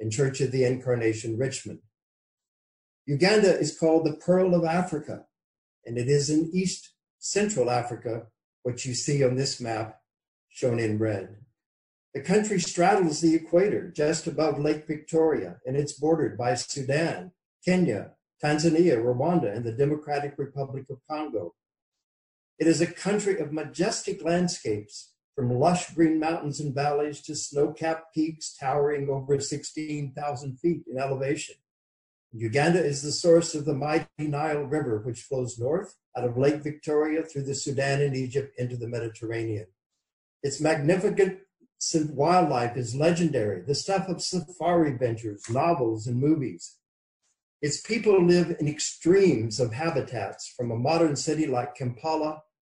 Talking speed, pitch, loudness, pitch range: 140 wpm, 145 Hz, -26 LUFS, 125-165 Hz